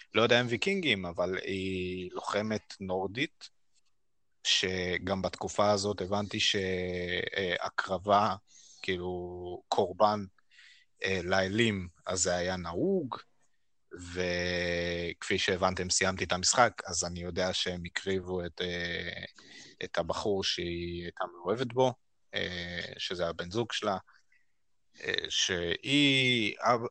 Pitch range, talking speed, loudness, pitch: 90-110 Hz, 95 wpm, -31 LUFS, 95 Hz